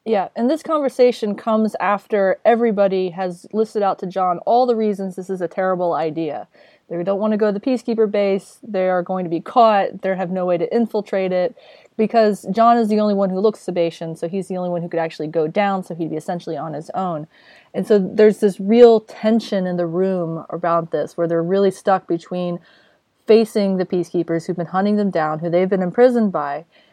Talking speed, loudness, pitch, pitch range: 215 wpm, -19 LUFS, 190 Hz, 175-215 Hz